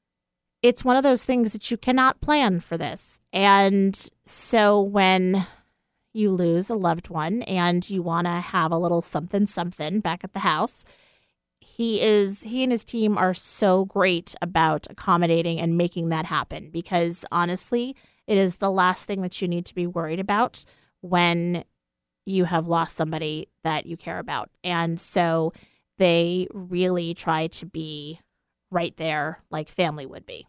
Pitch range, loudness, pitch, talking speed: 165-200 Hz, -23 LUFS, 180 Hz, 165 wpm